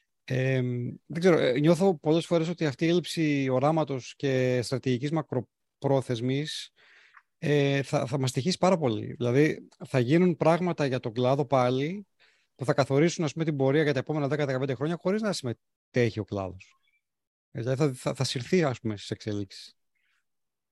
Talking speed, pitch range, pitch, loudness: 160 wpm, 125-160 Hz, 140 Hz, -27 LUFS